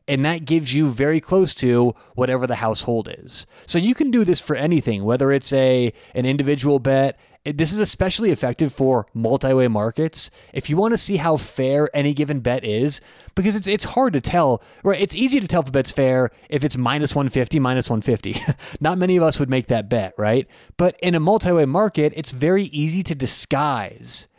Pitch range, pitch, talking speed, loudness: 130-165 Hz, 145 Hz, 200 wpm, -20 LUFS